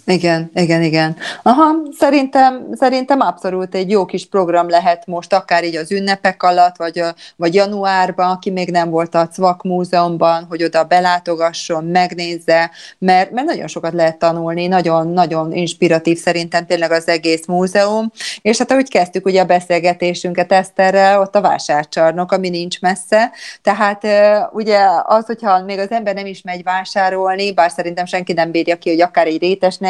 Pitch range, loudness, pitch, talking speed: 170-195 Hz, -15 LUFS, 180 Hz, 165 wpm